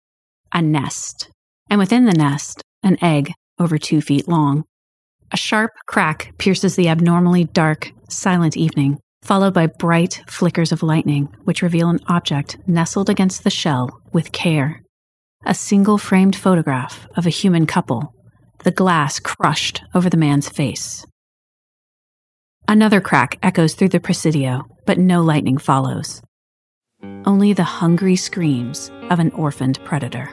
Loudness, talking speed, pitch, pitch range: -17 LUFS, 140 wpm, 165 Hz, 140-180 Hz